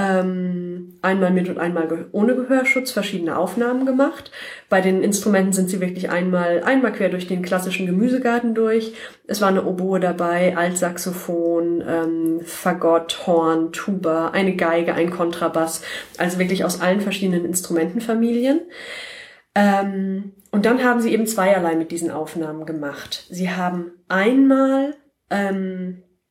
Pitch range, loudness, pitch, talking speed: 170-210 Hz, -20 LUFS, 185 Hz, 130 wpm